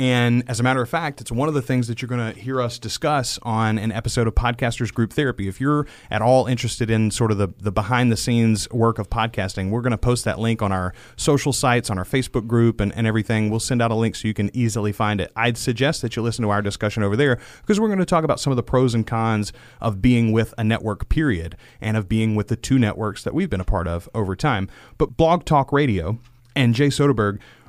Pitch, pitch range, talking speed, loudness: 115 Hz, 110-130 Hz, 260 wpm, -21 LUFS